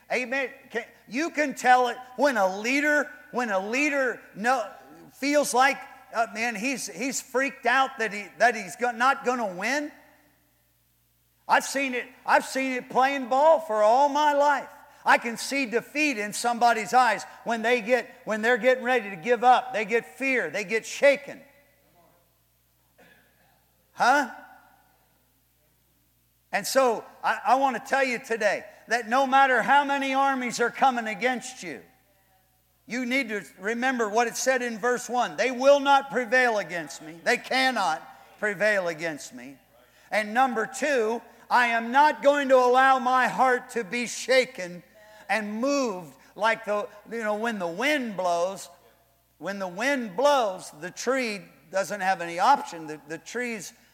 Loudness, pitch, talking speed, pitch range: -25 LUFS, 245 Hz, 160 wpm, 210-265 Hz